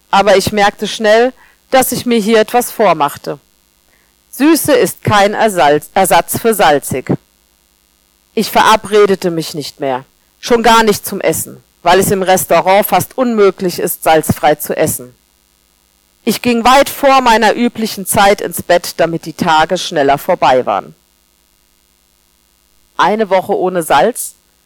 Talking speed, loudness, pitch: 135 wpm, -12 LUFS, 180 Hz